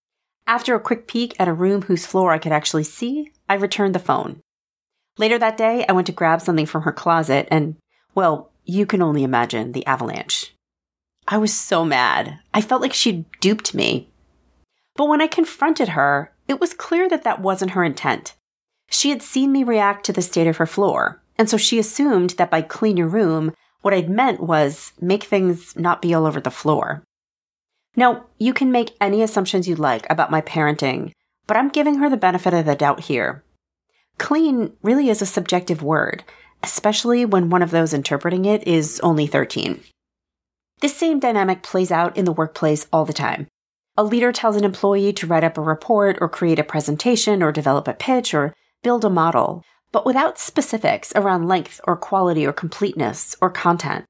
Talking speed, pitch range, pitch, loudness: 190 wpm, 160-225 Hz, 190 Hz, -19 LUFS